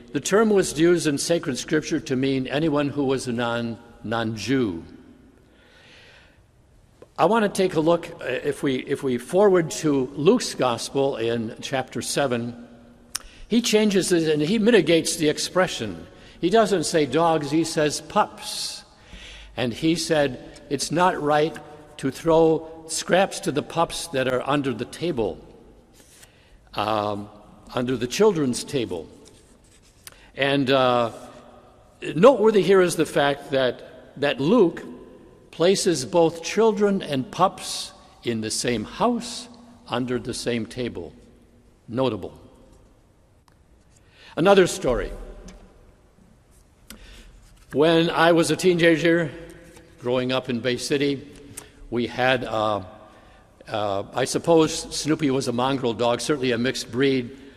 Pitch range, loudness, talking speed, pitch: 120-170 Hz, -22 LUFS, 125 wpm, 145 Hz